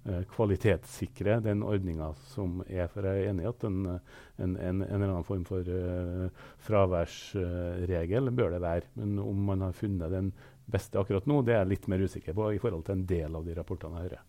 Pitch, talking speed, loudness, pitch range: 95 Hz, 195 wpm, -32 LUFS, 90-105 Hz